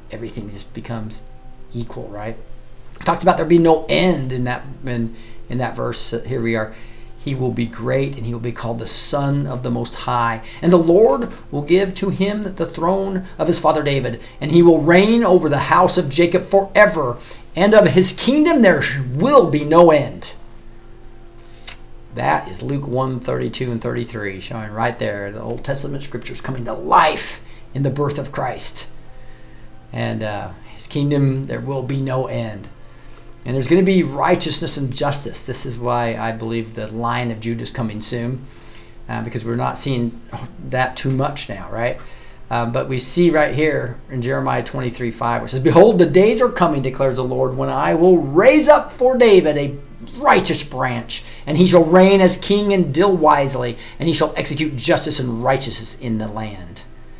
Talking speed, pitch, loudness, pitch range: 185 wpm, 130 Hz, -17 LUFS, 115-160 Hz